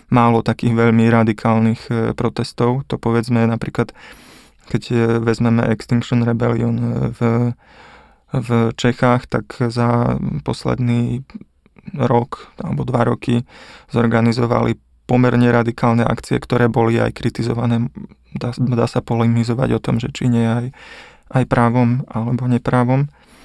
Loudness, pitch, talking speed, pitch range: -18 LUFS, 120 Hz, 115 wpm, 115-125 Hz